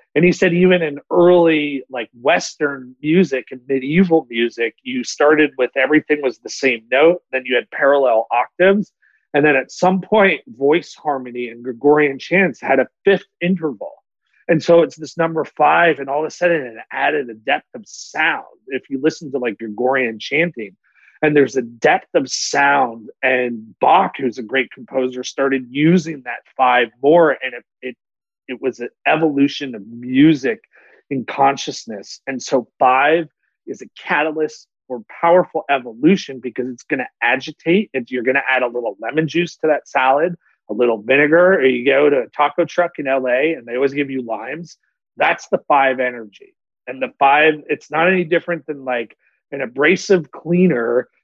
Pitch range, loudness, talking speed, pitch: 130-170 Hz, -17 LUFS, 175 wpm, 145 Hz